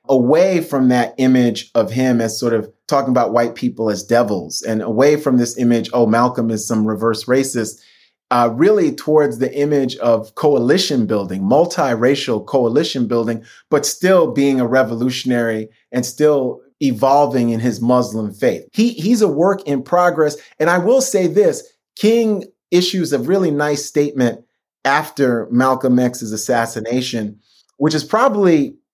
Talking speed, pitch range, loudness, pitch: 150 wpm, 115-150 Hz, -16 LUFS, 130 Hz